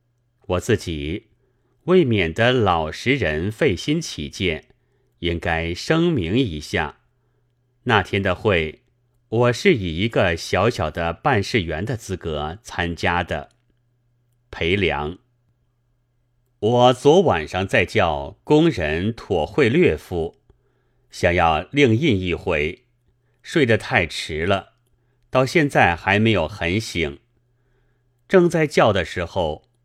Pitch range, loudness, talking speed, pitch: 90-125 Hz, -20 LUFS, 160 characters per minute, 120 Hz